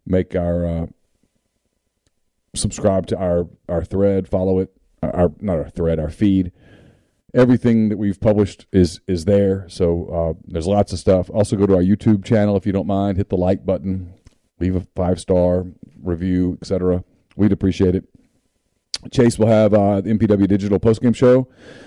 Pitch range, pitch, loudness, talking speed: 90-105 Hz, 95 Hz, -18 LUFS, 170 wpm